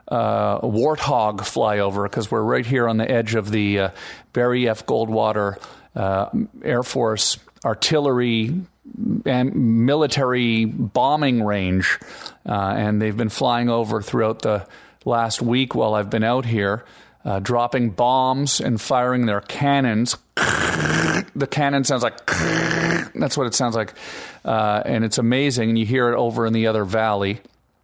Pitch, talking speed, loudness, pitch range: 115 Hz, 150 wpm, -20 LUFS, 110-125 Hz